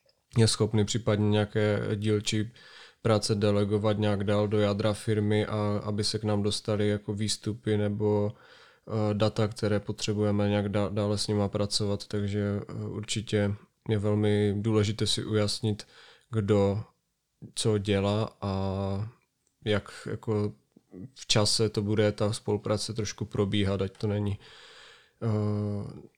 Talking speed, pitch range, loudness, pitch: 120 wpm, 105-110 Hz, -28 LUFS, 105 Hz